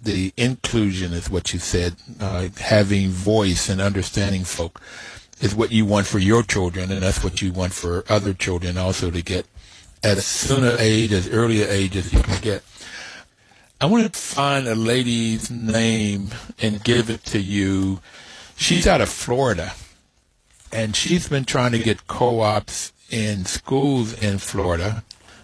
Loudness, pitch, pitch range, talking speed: -21 LUFS, 105 Hz, 95-115 Hz, 165 wpm